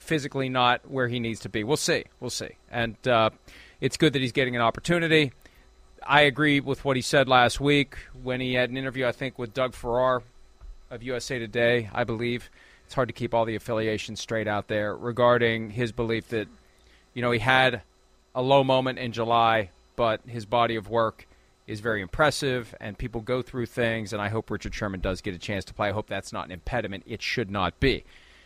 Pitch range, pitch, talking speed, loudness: 110-130 Hz, 120 Hz, 210 wpm, -26 LUFS